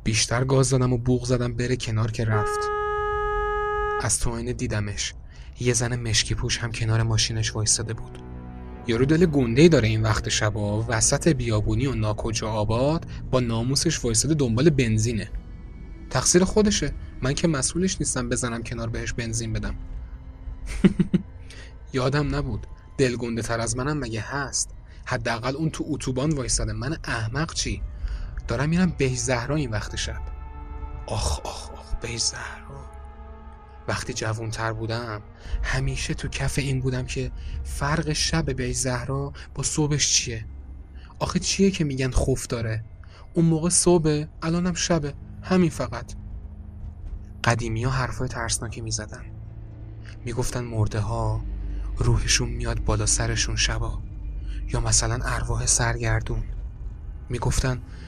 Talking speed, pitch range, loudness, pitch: 130 wpm, 105-135 Hz, -24 LUFS, 115 Hz